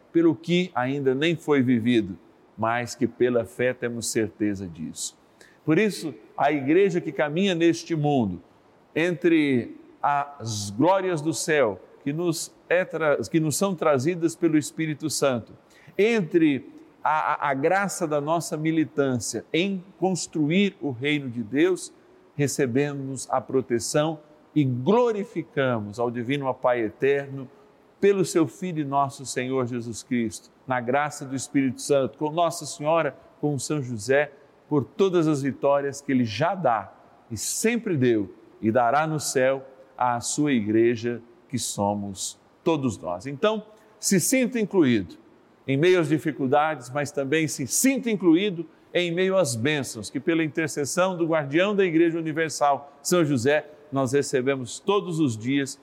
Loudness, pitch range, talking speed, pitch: -24 LUFS, 130-170 Hz, 140 wpm, 150 Hz